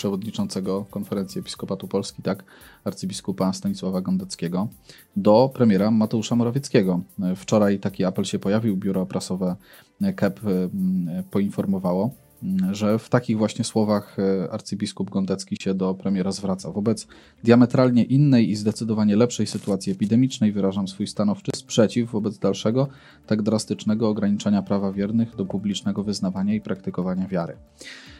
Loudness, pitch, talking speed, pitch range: -23 LUFS, 105 Hz, 120 wpm, 95-120 Hz